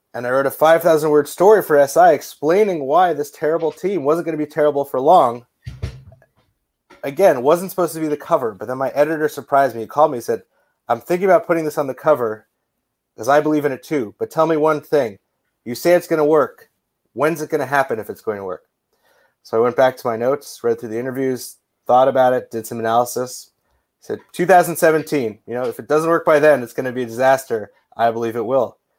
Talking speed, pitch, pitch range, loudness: 230 wpm, 145 Hz, 125-160 Hz, -17 LUFS